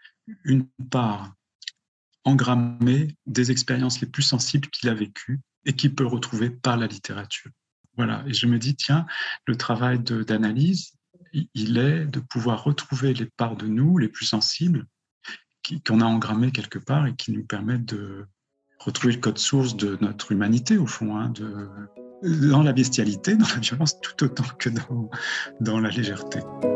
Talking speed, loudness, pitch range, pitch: 170 wpm, -24 LUFS, 110-140 Hz, 125 Hz